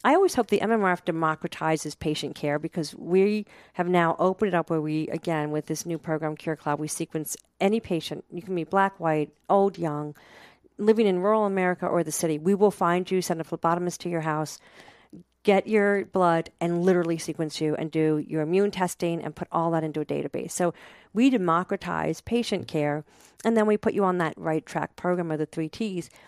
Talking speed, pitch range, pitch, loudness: 205 wpm, 155-195 Hz, 170 Hz, -26 LUFS